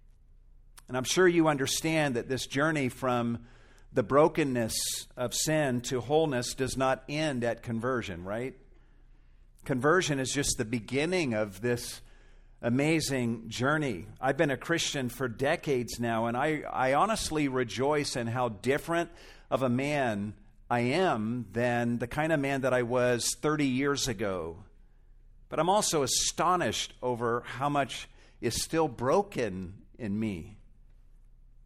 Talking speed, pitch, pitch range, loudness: 140 wpm, 125 Hz, 115-145 Hz, -29 LUFS